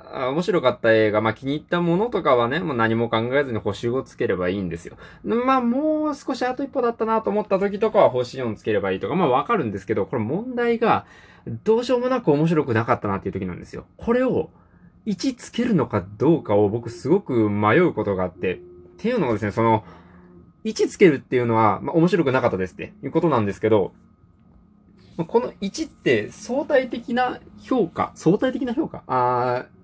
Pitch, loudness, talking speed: 140 Hz, -22 LUFS, 395 characters per minute